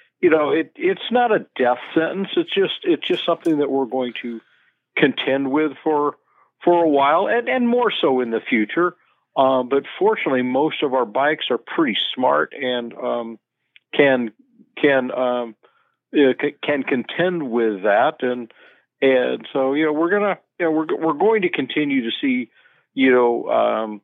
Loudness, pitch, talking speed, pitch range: -20 LUFS, 145 Hz, 175 wpm, 125-180 Hz